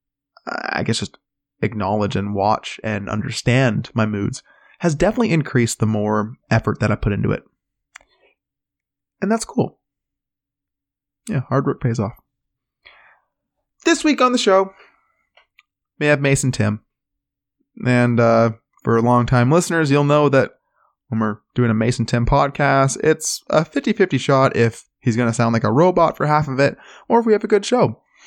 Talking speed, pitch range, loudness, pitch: 160 wpm, 110-155 Hz, -18 LUFS, 130 Hz